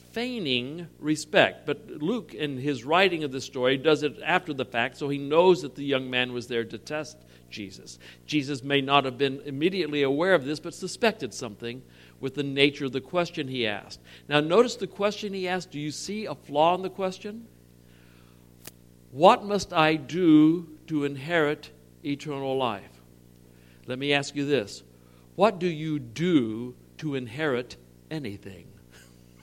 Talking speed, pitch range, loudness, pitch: 165 wpm, 105-160 Hz, -26 LUFS, 140 Hz